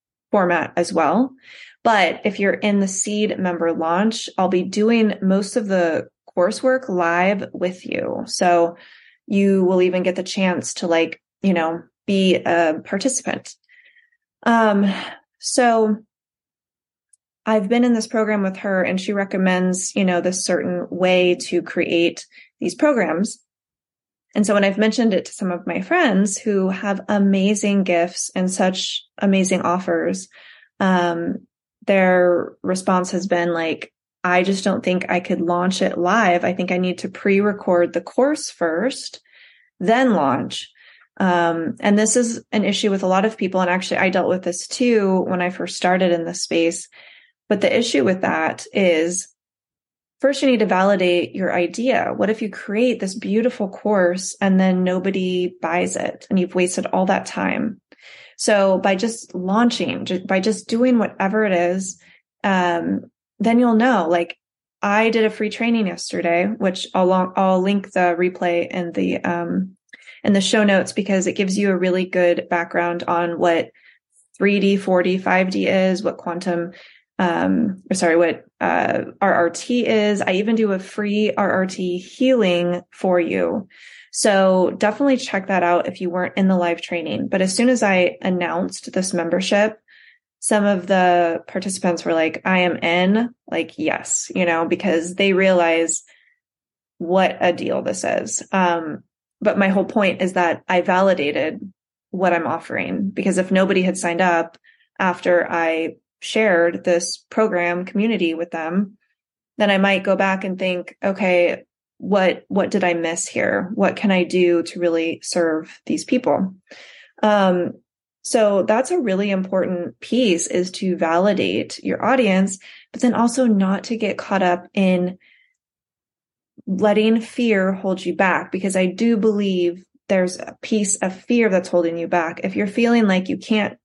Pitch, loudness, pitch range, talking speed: 190 Hz, -19 LUFS, 180-215 Hz, 160 wpm